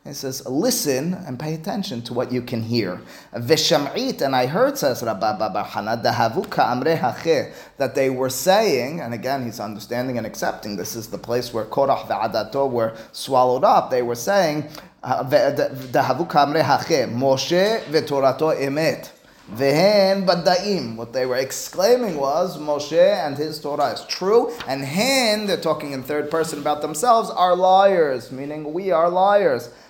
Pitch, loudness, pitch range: 145 Hz, -20 LUFS, 125-180 Hz